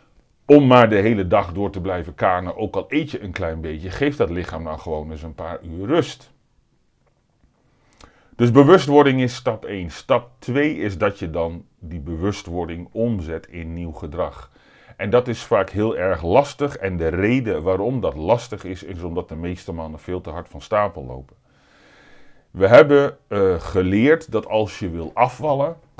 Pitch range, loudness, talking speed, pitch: 85-120 Hz, -19 LUFS, 180 wpm, 95 Hz